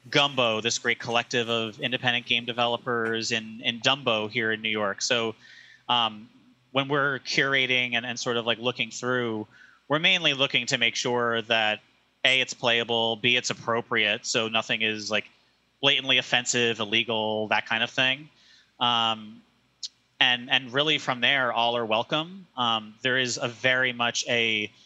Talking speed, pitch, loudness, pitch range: 160 wpm, 120 Hz, -24 LUFS, 115-130 Hz